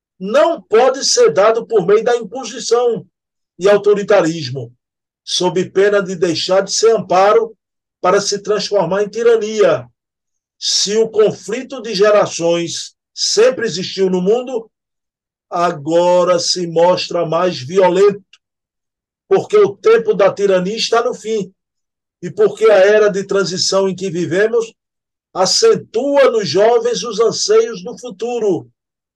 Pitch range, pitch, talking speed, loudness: 185-235 Hz, 205 Hz, 125 wpm, -14 LUFS